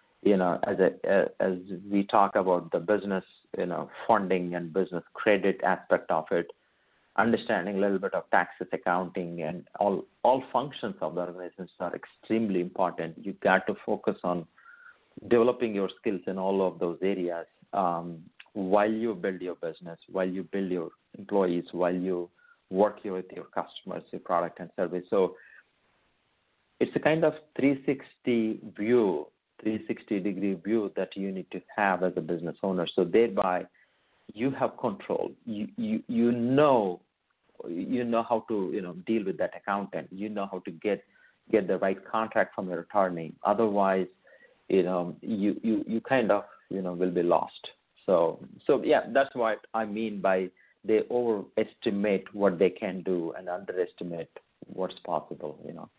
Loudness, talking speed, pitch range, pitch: -29 LUFS, 165 wpm, 90-110 Hz, 95 Hz